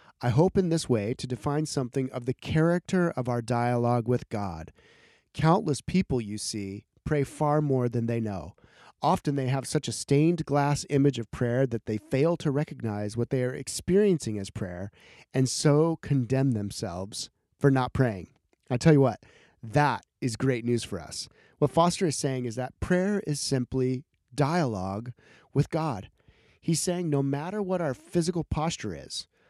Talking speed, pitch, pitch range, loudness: 175 wpm, 135 Hz, 120-155 Hz, -28 LUFS